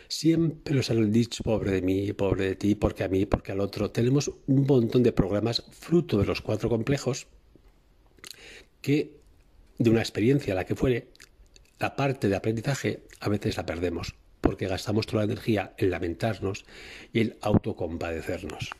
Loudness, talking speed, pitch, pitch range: -27 LUFS, 165 wpm, 110 Hz, 95-125 Hz